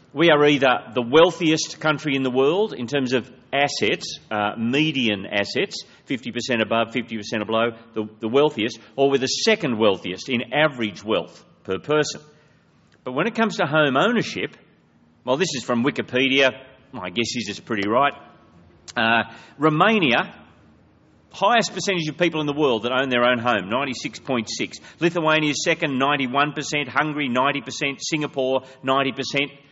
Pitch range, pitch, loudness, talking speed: 115-150 Hz, 135 Hz, -21 LUFS, 150 wpm